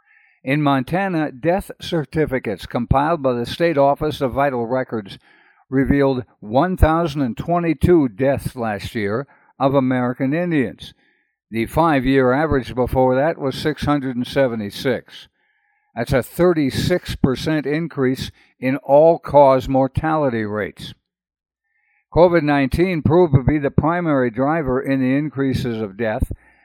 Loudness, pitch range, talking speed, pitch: -19 LUFS, 130-160 Hz, 115 wpm, 140 Hz